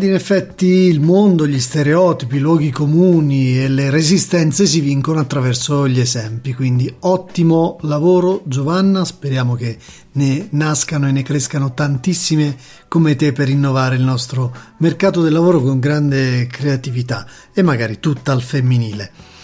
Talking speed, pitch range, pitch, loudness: 140 wpm, 130-165 Hz, 145 Hz, -15 LUFS